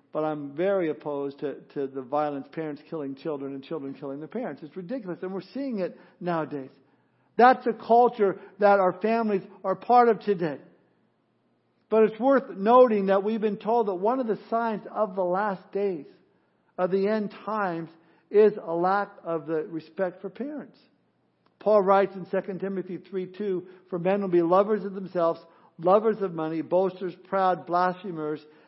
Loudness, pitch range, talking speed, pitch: -26 LUFS, 165-205 Hz, 165 wpm, 190 Hz